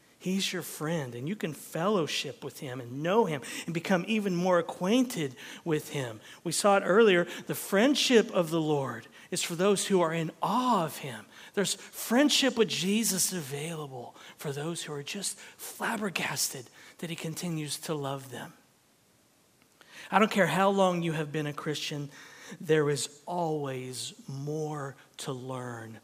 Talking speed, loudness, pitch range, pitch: 160 wpm, -29 LUFS, 145-195 Hz, 165 Hz